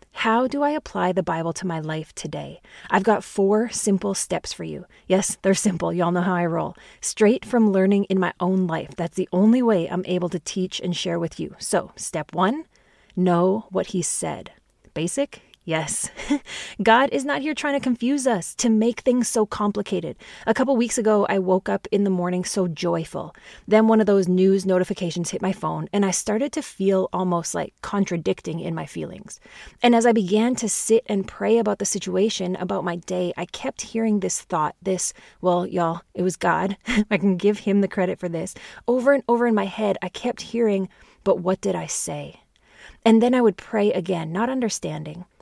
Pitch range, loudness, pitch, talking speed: 180-225 Hz, -22 LUFS, 195 Hz, 200 wpm